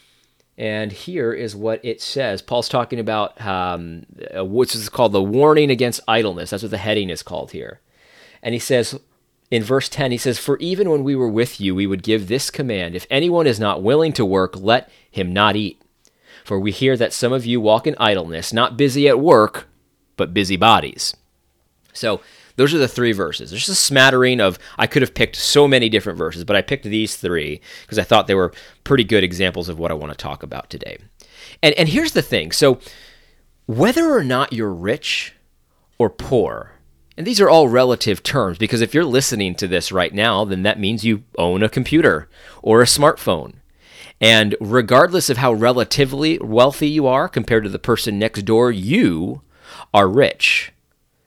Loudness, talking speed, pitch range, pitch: -17 LUFS, 195 wpm, 95-130 Hz, 110 Hz